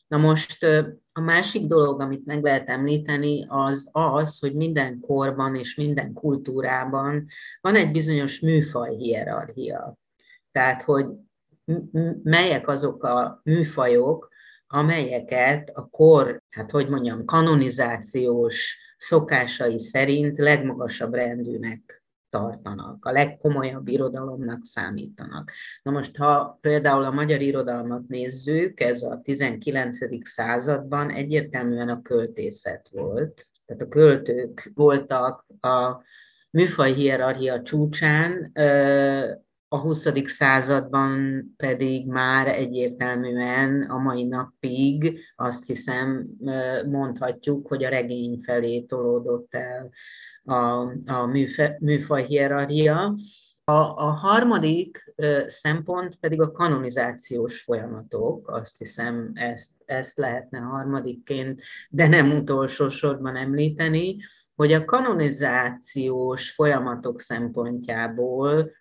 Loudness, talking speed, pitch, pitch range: -23 LUFS, 105 wpm, 135 Hz, 125-150 Hz